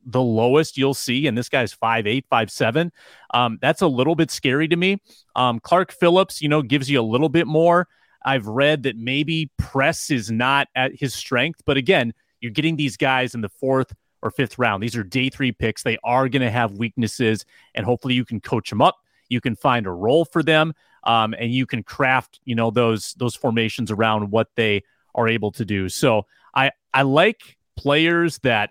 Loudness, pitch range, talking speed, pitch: -20 LUFS, 115-145 Hz, 210 wpm, 130 Hz